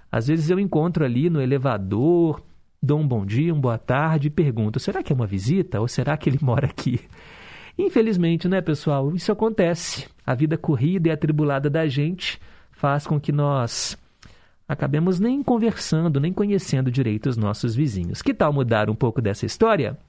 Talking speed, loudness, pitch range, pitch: 175 wpm, -22 LUFS, 130-170 Hz, 150 Hz